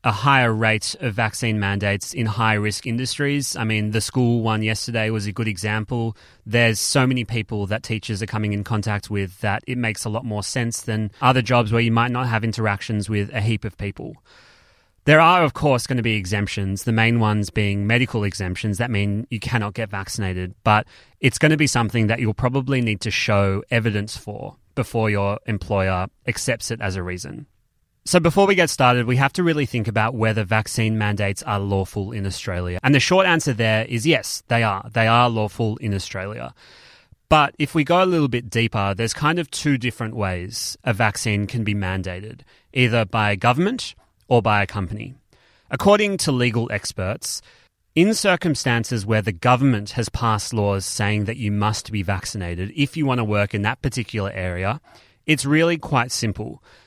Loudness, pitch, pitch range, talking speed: -21 LUFS, 110 Hz, 105-125 Hz, 195 wpm